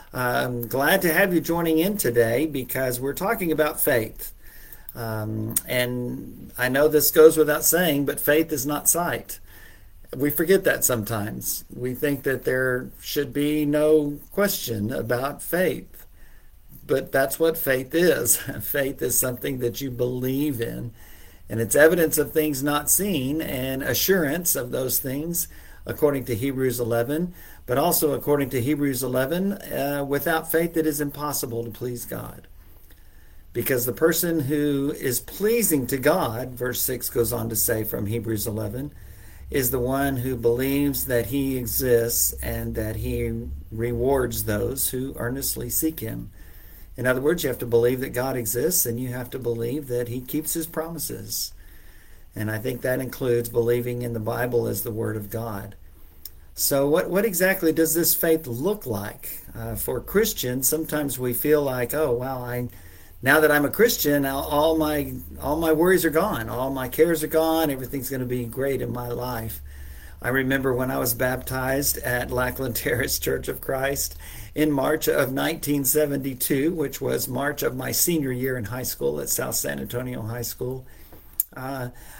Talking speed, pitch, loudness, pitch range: 165 wpm, 130 Hz, -23 LUFS, 115-150 Hz